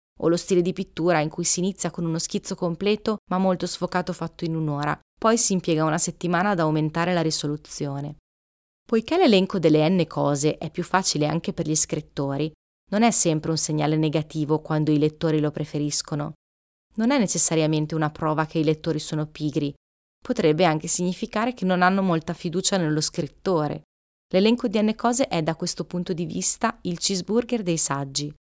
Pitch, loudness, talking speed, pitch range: 165 Hz, -23 LUFS, 180 wpm, 155-185 Hz